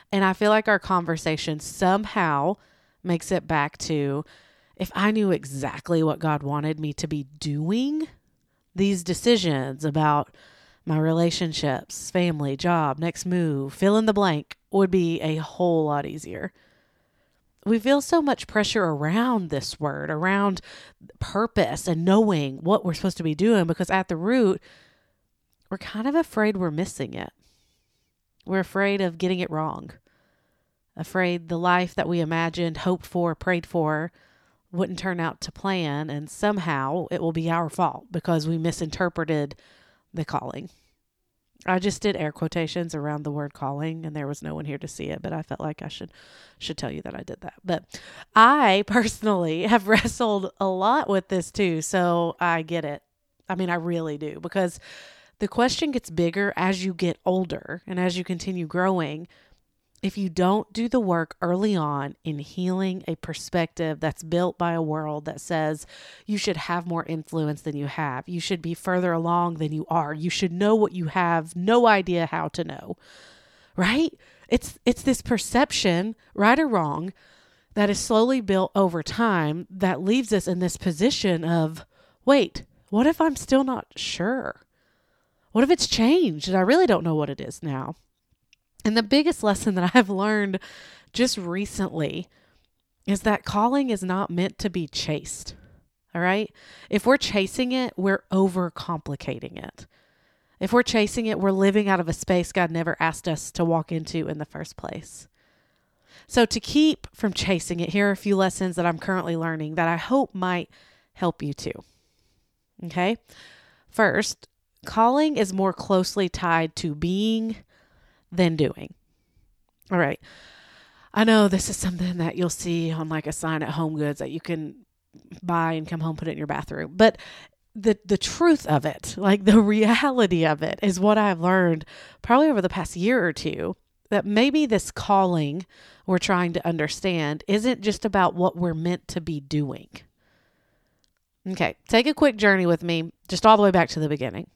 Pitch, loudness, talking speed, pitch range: 180 Hz, -24 LUFS, 175 wpm, 160-205 Hz